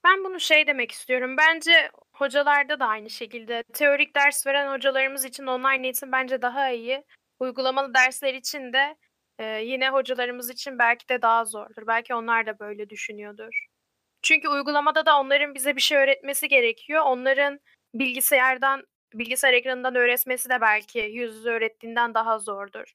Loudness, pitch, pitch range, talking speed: -22 LUFS, 260 Hz, 235-280 Hz, 150 wpm